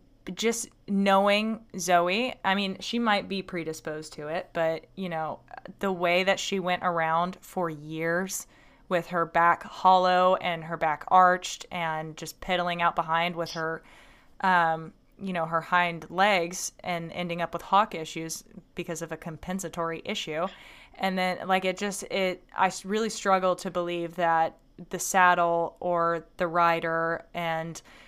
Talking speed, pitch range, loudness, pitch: 155 wpm, 165-190 Hz, -27 LUFS, 175 Hz